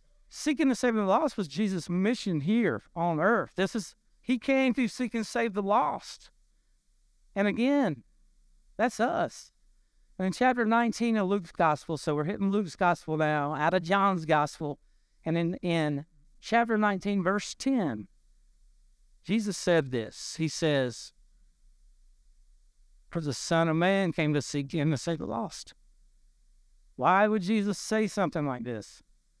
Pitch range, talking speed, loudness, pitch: 150-215 Hz, 150 wpm, -28 LUFS, 185 Hz